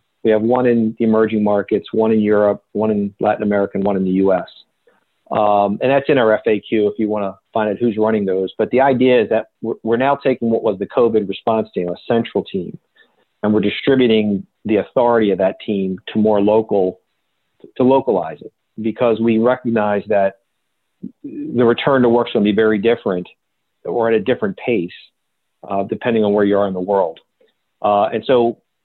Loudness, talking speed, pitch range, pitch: -17 LUFS, 200 wpm, 100-115 Hz, 110 Hz